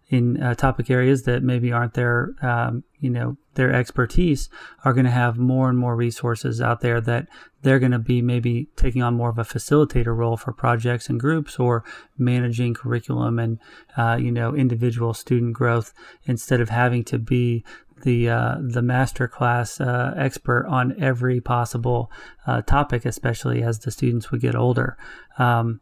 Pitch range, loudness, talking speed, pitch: 120-130 Hz, -22 LUFS, 175 wpm, 125 Hz